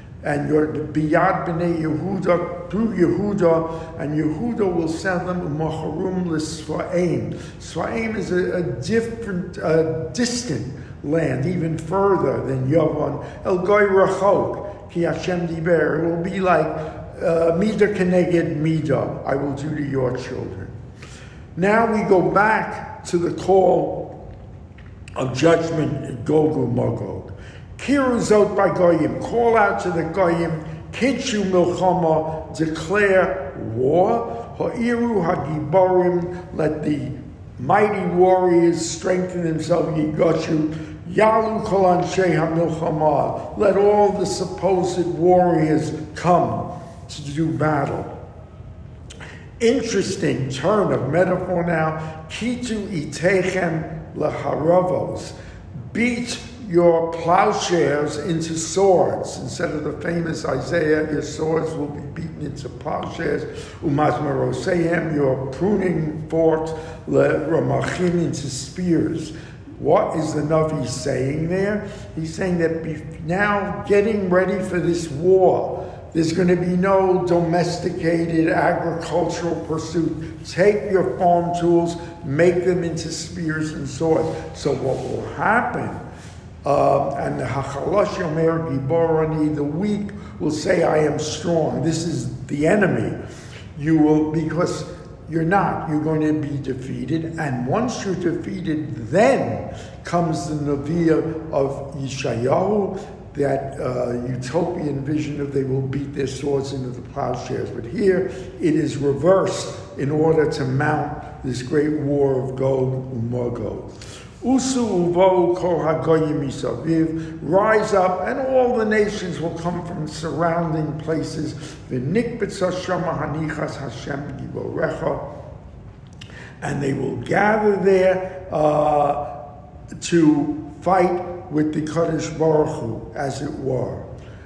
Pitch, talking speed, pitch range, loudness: 165 Hz, 110 wpm, 150-180 Hz, -21 LUFS